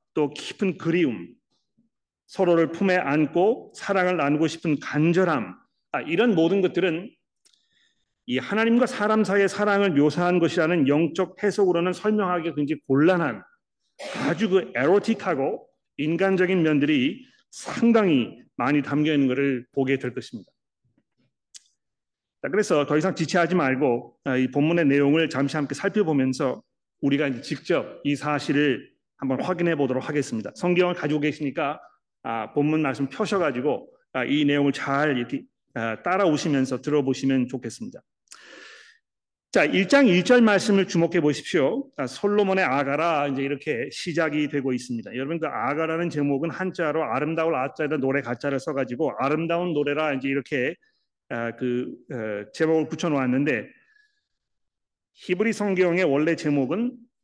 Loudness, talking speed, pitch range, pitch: -23 LUFS, 310 characters per minute, 140-185 Hz, 155 Hz